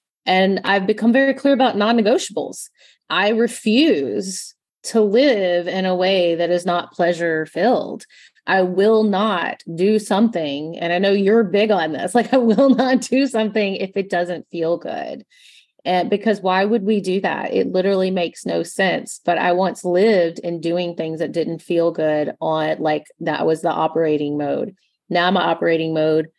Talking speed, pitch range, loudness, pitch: 175 wpm, 170-215 Hz, -18 LUFS, 185 Hz